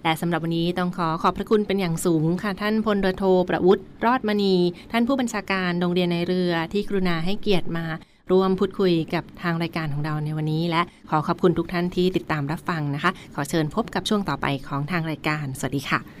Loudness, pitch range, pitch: -23 LUFS, 160-190 Hz, 175 Hz